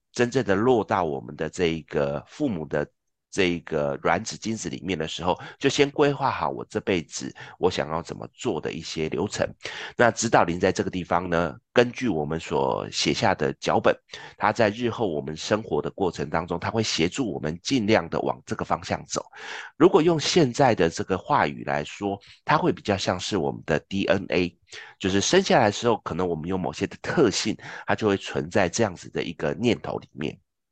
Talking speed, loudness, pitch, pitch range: 295 characters per minute, -25 LUFS, 90 Hz, 80-110 Hz